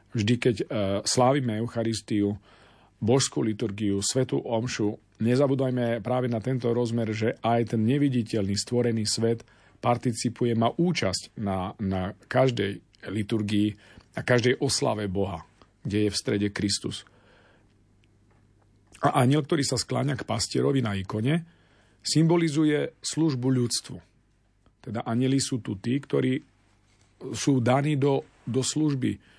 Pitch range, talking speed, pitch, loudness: 105-130 Hz, 120 wpm, 115 Hz, -26 LUFS